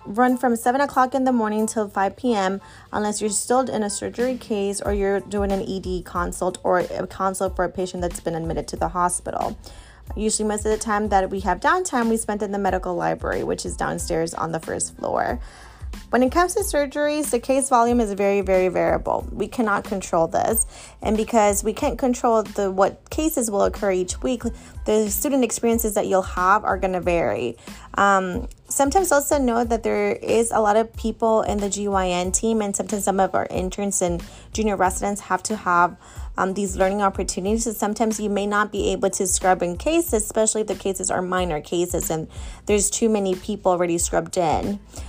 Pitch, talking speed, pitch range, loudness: 205 Hz, 205 wpm, 190-230 Hz, -22 LUFS